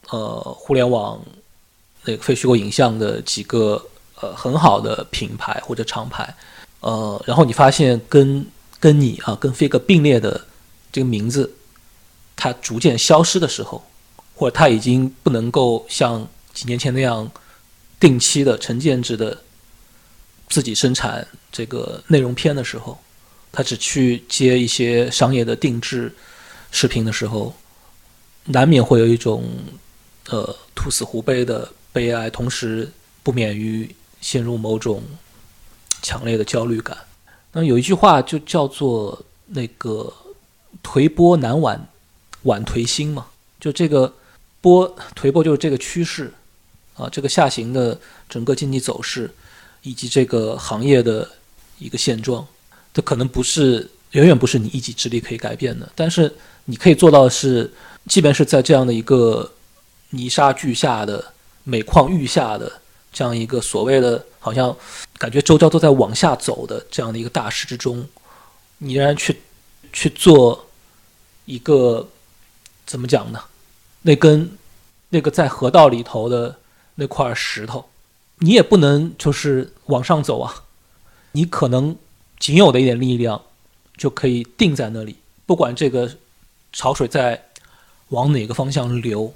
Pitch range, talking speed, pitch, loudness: 115-145 Hz, 220 characters per minute, 130 Hz, -17 LUFS